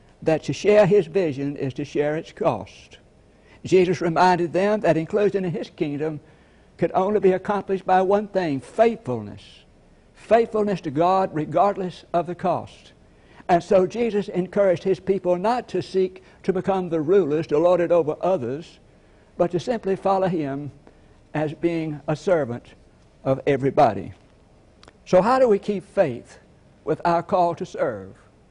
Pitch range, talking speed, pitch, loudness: 155-195 Hz, 155 wpm, 180 Hz, -22 LUFS